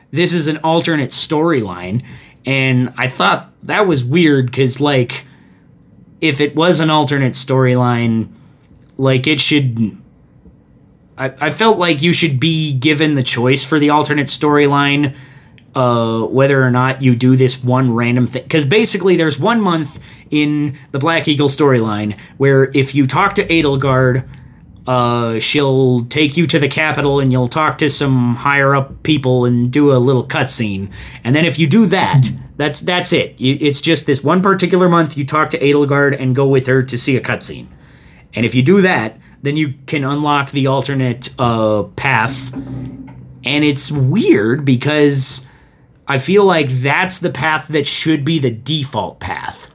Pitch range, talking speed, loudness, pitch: 130-155 Hz, 165 wpm, -13 LUFS, 140 Hz